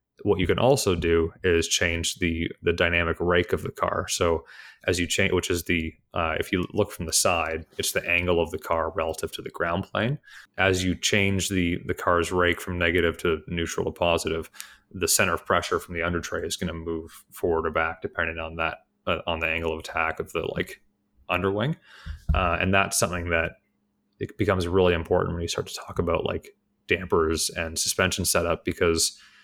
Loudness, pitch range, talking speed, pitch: -25 LUFS, 85-95 Hz, 205 wpm, 85 Hz